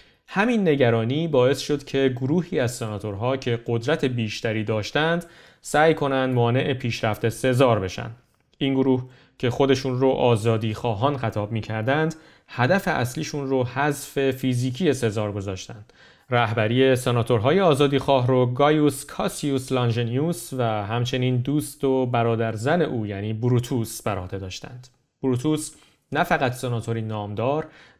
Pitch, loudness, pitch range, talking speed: 130 Hz, -23 LUFS, 115-145 Hz, 125 wpm